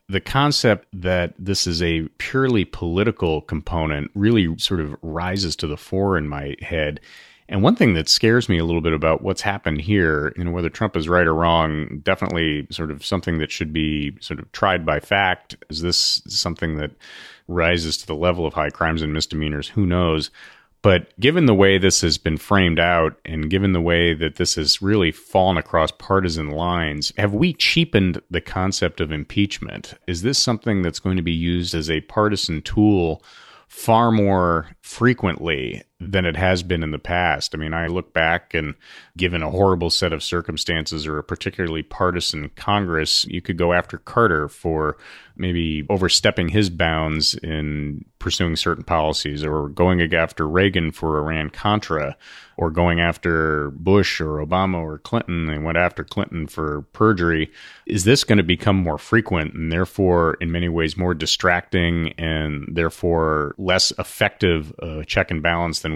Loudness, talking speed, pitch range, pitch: -20 LUFS, 175 wpm, 80-95 Hz, 85 Hz